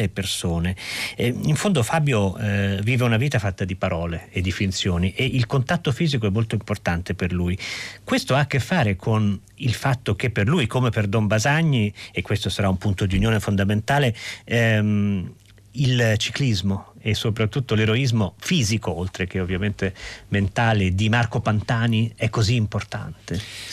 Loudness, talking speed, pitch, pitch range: -22 LUFS, 160 wpm, 110 Hz, 100-120 Hz